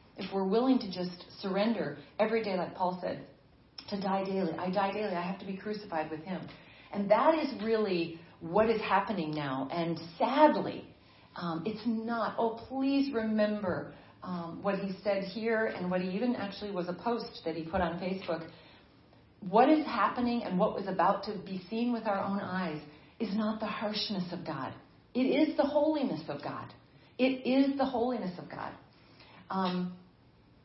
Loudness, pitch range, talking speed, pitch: -32 LUFS, 175-225 Hz, 180 wpm, 200 Hz